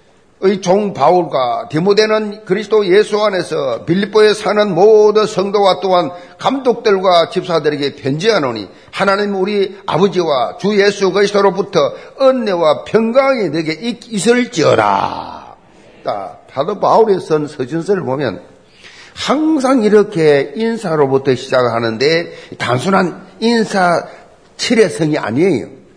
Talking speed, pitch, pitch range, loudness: 270 characters per minute, 195 Hz, 160-215 Hz, -14 LUFS